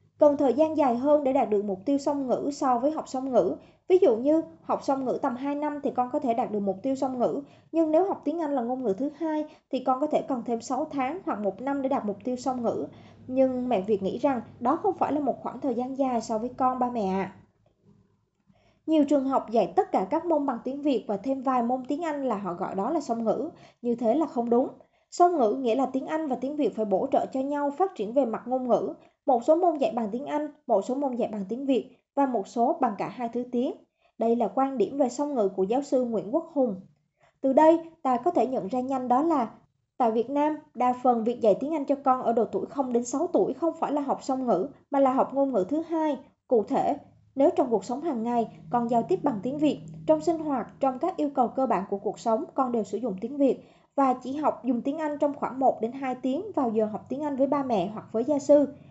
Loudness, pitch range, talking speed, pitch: -27 LUFS, 235-295 Hz, 270 wpm, 265 Hz